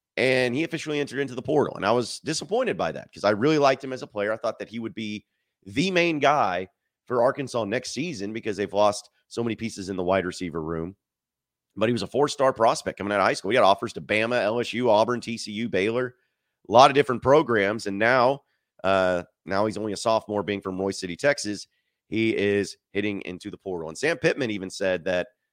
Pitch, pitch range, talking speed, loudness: 105 Hz, 95-125 Hz, 225 wpm, -25 LUFS